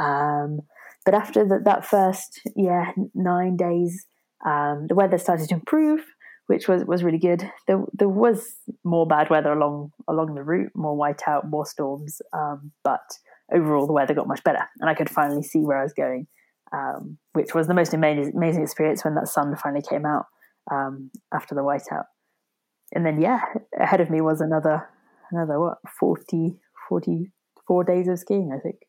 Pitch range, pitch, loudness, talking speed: 150-185 Hz, 165 Hz, -23 LUFS, 180 wpm